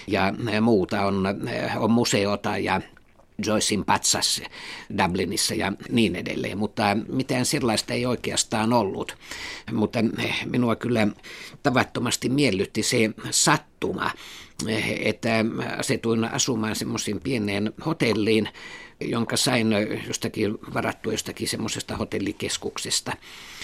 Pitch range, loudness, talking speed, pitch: 105-115 Hz, -24 LUFS, 95 wpm, 110 Hz